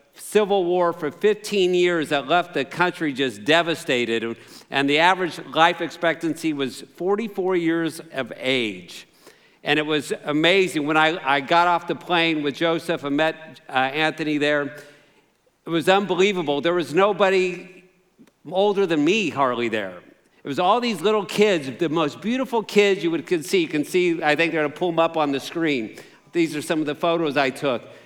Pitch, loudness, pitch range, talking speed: 165 Hz, -21 LUFS, 150-190 Hz, 185 wpm